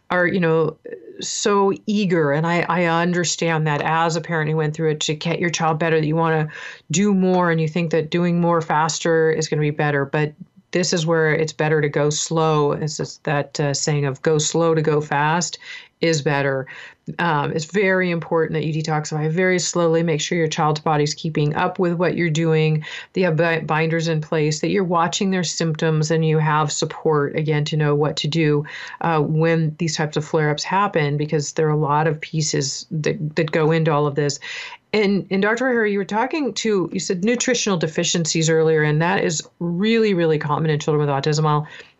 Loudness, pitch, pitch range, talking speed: -20 LUFS, 160 Hz, 155-175 Hz, 210 wpm